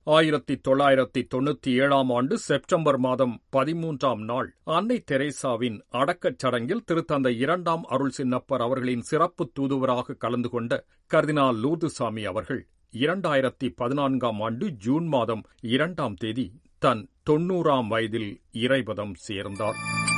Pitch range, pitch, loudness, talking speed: 120-150 Hz, 135 Hz, -26 LUFS, 110 wpm